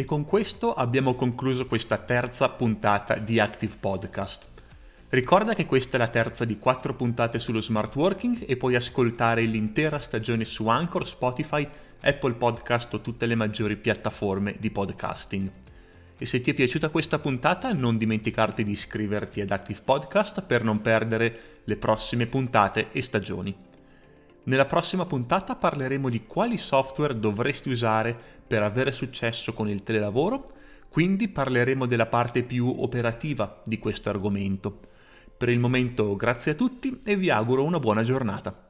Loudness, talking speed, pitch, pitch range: -26 LUFS, 150 wpm, 120 Hz, 110-135 Hz